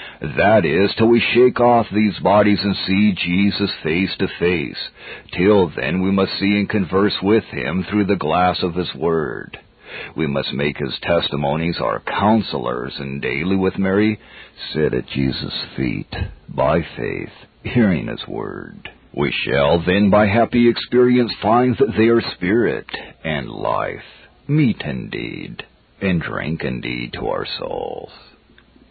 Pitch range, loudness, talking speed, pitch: 90-110 Hz, -18 LUFS, 145 wpm, 100 Hz